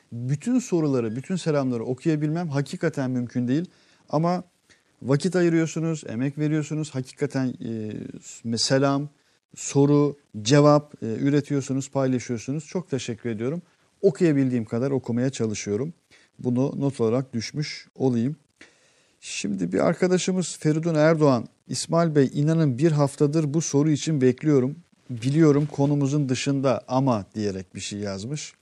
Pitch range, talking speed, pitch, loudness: 125-155 Hz, 115 wpm, 140 Hz, -24 LUFS